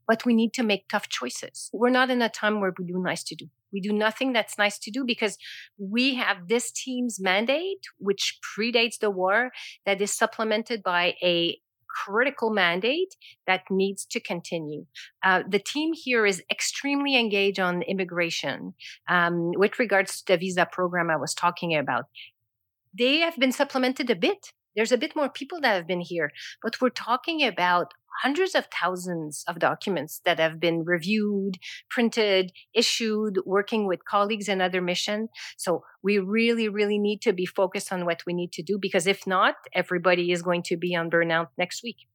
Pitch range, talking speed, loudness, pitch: 180-230 Hz, 180 wpm, -25 LUFS, 200 Hz